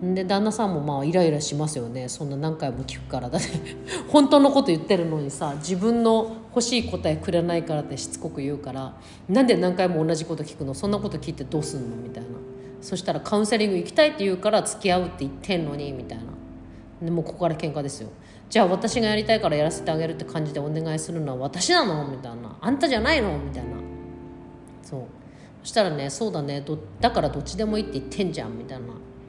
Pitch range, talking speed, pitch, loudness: 130-190 Hz, 465 characters per minute, 155 Hz, -24 LUFS